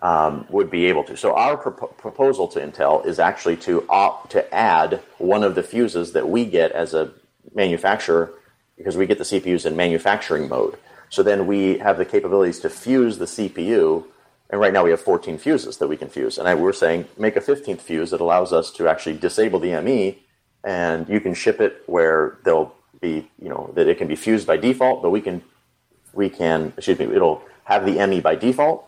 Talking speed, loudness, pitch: 210 wpm, -20 LUFS, 160 Hz